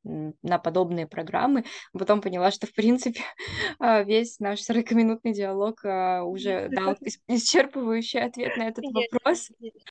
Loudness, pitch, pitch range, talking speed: -26 LUFS, 225 Hz, 195-240 Hz, 115 wpm